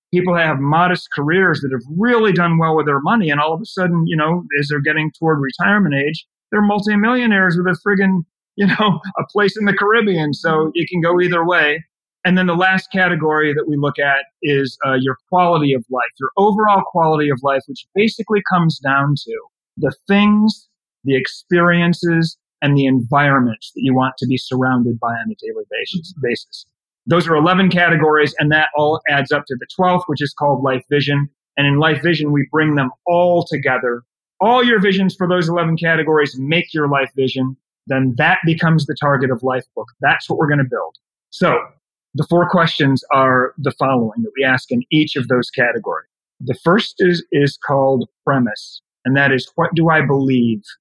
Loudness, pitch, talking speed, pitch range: -16 LUFS, 155 Hz, 195 wpm, 140-180 Hz